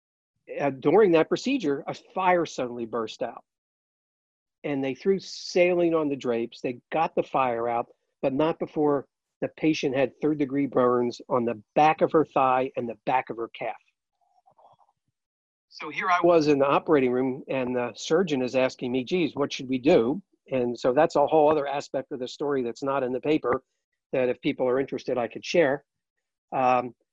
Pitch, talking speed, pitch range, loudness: 140 Hz, 185 wpm, 125-155 Hz, -25 LUFS